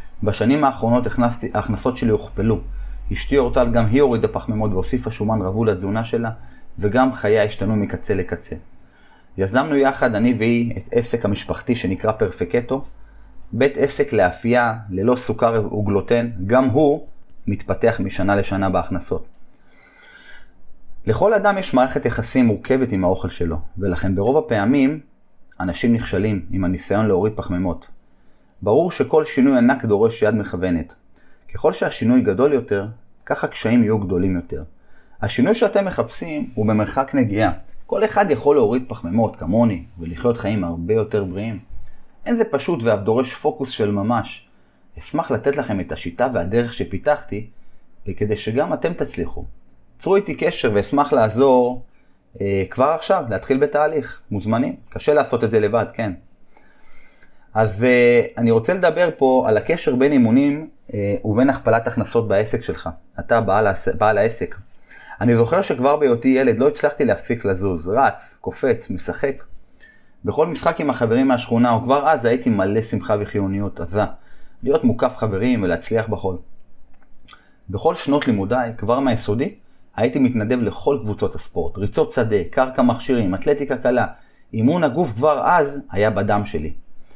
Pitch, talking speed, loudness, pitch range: 115 Hz, 140 wpm, -19 LUFS, 100-130 Hz